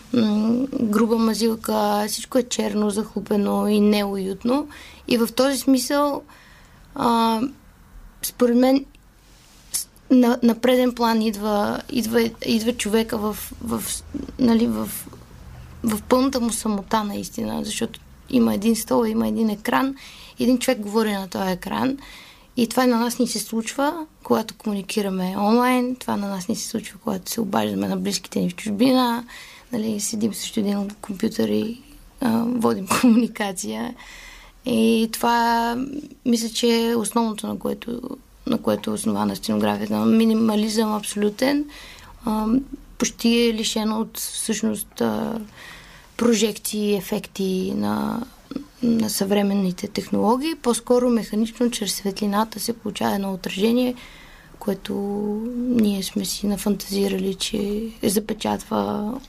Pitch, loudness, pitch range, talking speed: 225 Hz, -22 LUFS, 210-240 Hz, 120 wpm